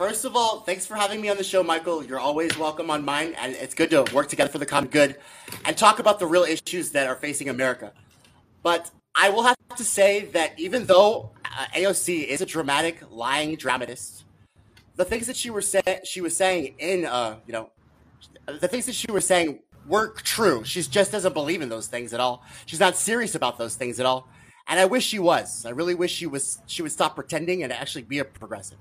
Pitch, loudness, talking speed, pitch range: 165 Hz, -23 LUFS, 225 wpm, 130-190 Hz